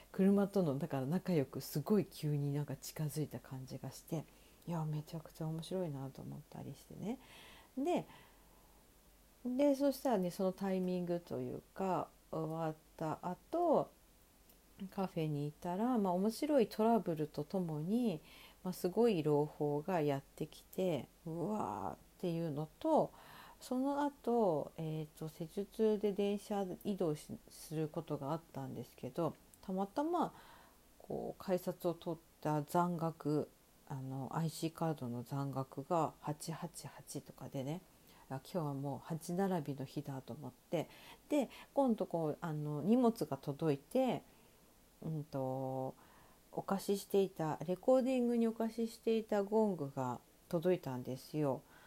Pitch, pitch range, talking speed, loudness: 165 Hz, 145-200 Hz, 270 characters per minute, -39 LUFS